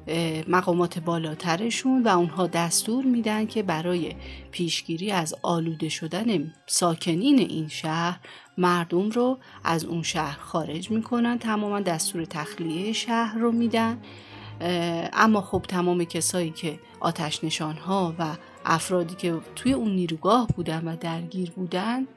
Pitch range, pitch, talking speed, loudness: 165-210 Hz, 175 Hz, 120 wpm, -26 LUFS